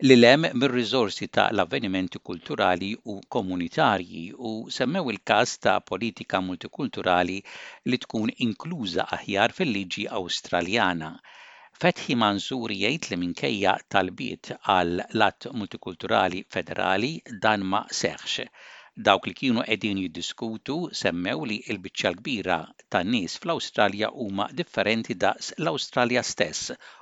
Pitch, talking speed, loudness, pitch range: 105 Hz, 120 wpm, -26 LUFS, 95-115 Hz